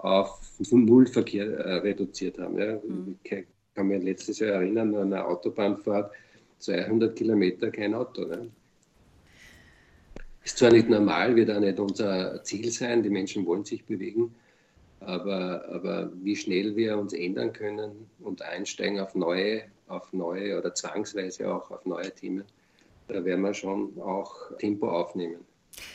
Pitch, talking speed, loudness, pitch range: 100 Hz, 145 wpm, -28 LUFS, 95-110 Hz